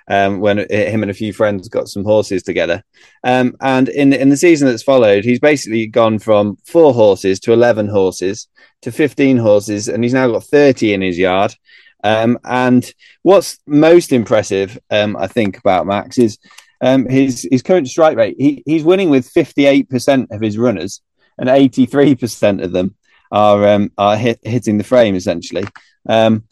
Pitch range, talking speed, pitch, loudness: 105-135 Hz, 175 wpm, 120 Hz, -13 LUFS